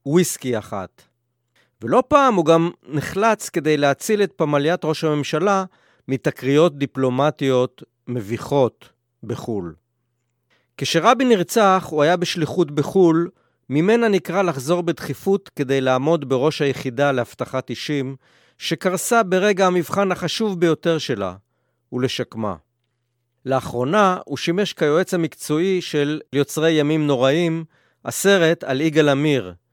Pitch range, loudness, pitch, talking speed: 130-175 Hz, -20 LUFS, 150 Hz, 105 wpm